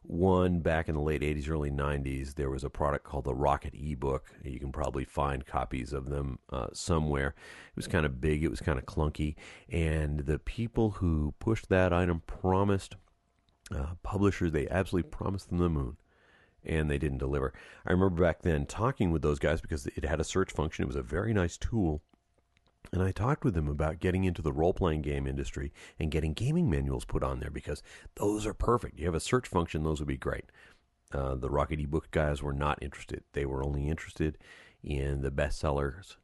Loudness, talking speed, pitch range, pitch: -32 LUFS, 205 wpm, 70-90 Hz, 75 Hz